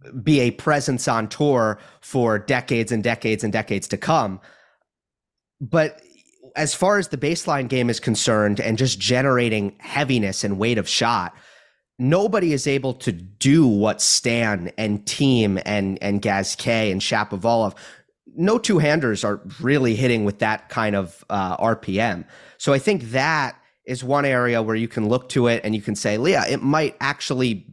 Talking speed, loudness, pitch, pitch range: 165 wpm, -21 LUFS, 120 Hz, 110-140 Hz